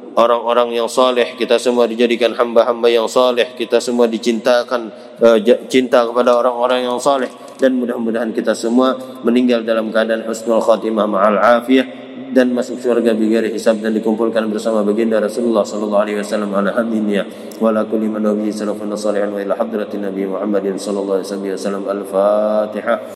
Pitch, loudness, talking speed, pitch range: 115 Hz, -16 LUFS, 125 wpm, 105-120 Hz